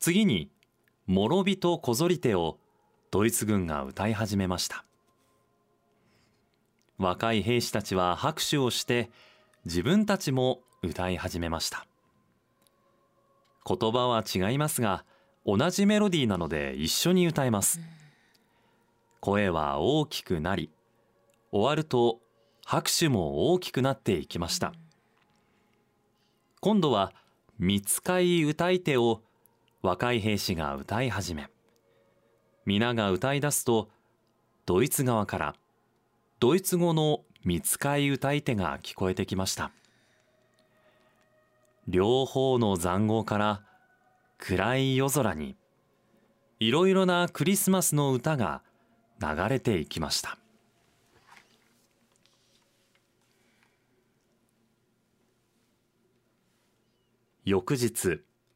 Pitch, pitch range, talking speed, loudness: 115 Hz, 100-135 Hz, 190 characters per minute, -28 LUFS